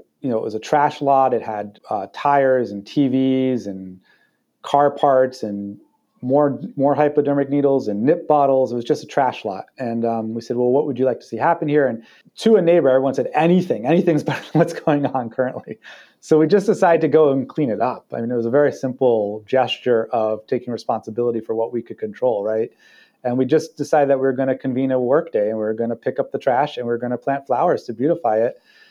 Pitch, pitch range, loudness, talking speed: 130 Hz, 115-145 Hz, -19 LUFS, 240 wpm